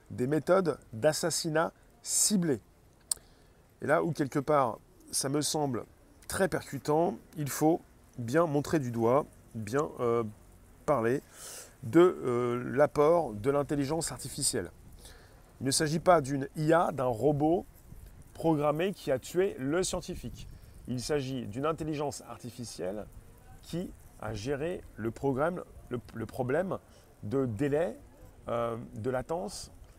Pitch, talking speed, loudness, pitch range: 135 Hz, 120 wpm, -31 LUFS, 115-155 Hz